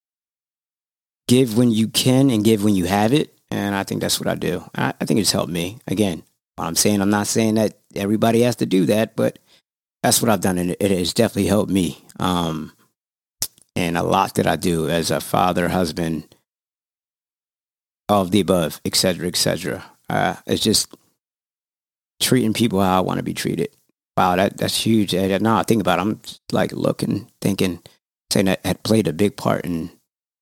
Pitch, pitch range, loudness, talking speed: 100 Hz, 90-110 Hz, -20 LUFS, 195 wpm